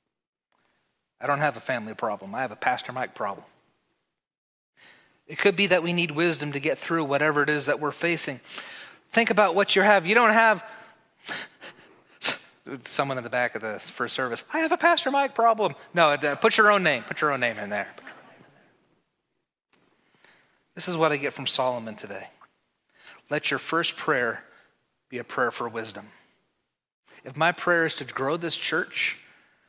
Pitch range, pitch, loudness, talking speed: 140-210 Hz, 165 Hz, -24 LUFS, 180 wpm